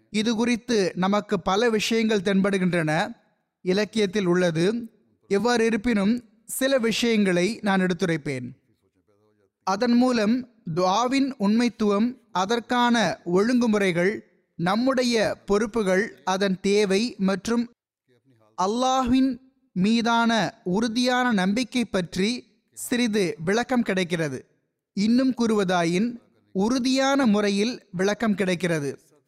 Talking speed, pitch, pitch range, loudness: 80 wpm, 210 Hz, 185-235 Hz, -23 LUFS